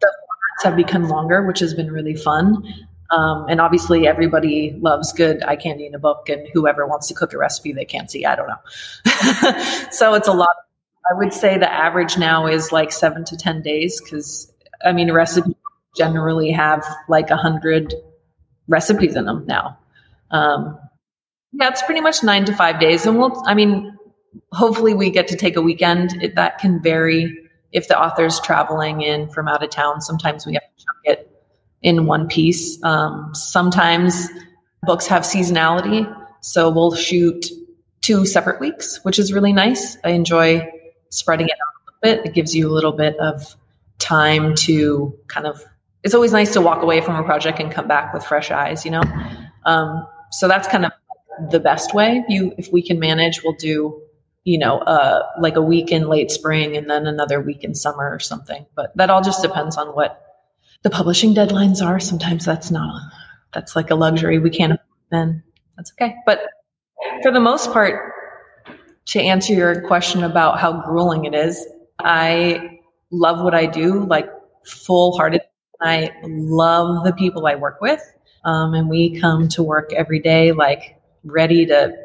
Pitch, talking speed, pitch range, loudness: 165 Hz, 180 wpm, 155-185 Hz, -17 LUFS